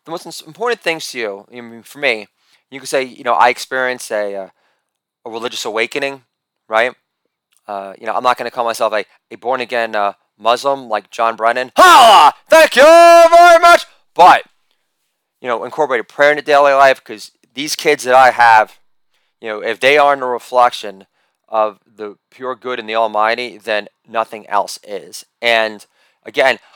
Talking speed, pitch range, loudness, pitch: 180 wpm, 110-145 Hz, -12 LUFS, 125 Hz